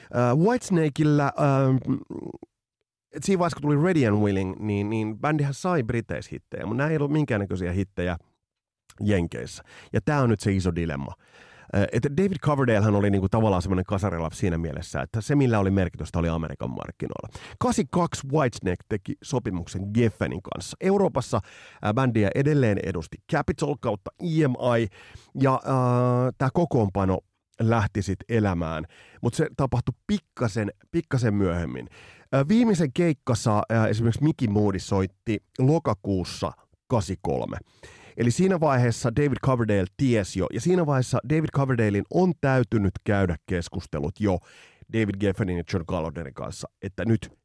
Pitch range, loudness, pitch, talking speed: 95-140 Hz, -25 LUFS, 115 Hz, 135 wpm